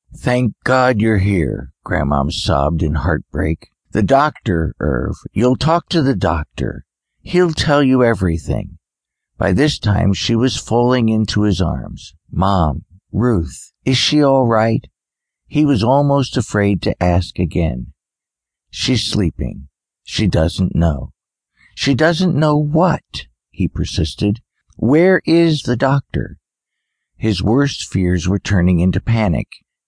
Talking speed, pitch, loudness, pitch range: 125 wpm, 105 Hz, -16 LUFS, 85-130 Hz